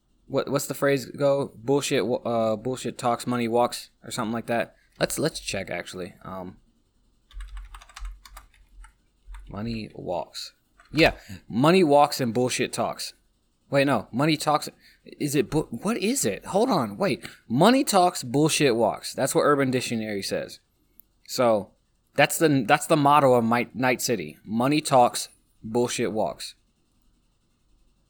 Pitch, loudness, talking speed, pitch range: 125 Hz, -24 LUFS, 135 wpm, 115-145 Hz